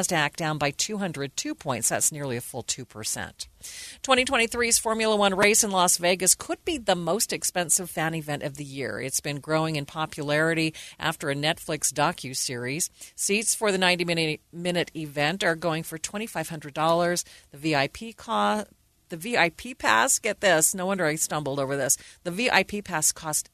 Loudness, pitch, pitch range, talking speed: -25 LUFS, 160 Hz, 150-195 Hz, 160 wpm